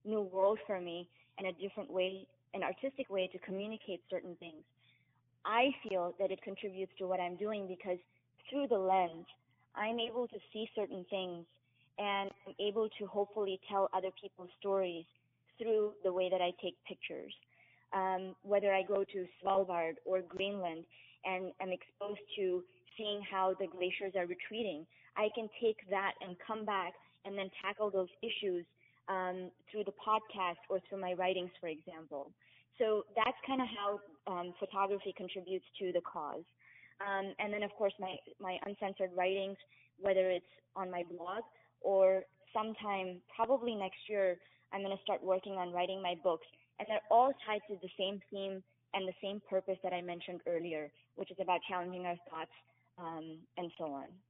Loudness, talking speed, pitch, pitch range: -38 LUFS, 170 wpm, 190 Hz, 180-200 Hz